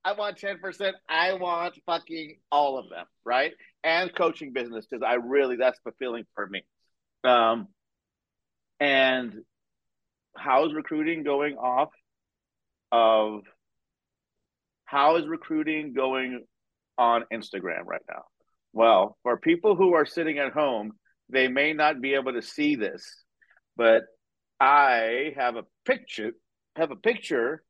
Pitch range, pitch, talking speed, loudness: 120-170 Hz, 140 Hz, 130 wpm, -25 LUFS